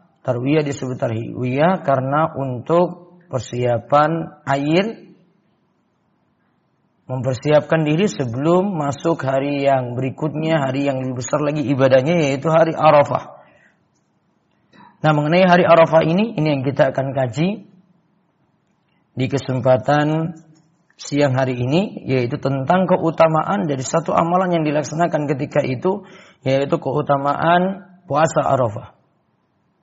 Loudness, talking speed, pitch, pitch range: -18 LUFS, 105 wpm, 150 Hz, 135-170 Hz